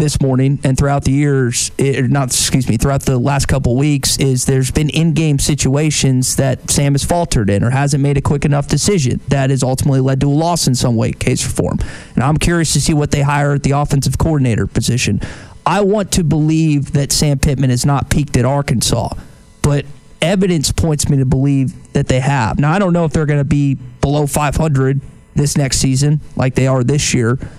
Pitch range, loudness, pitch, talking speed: 130-150 Hz, -14 LUFS, 140 Hz, 215 wpm